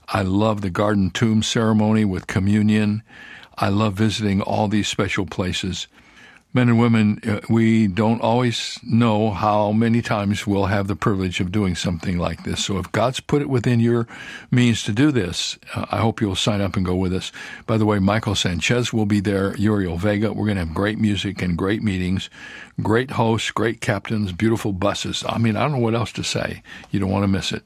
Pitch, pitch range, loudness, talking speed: 105 Hz, 100-115 Hz, -20 LUFS, 205 wpm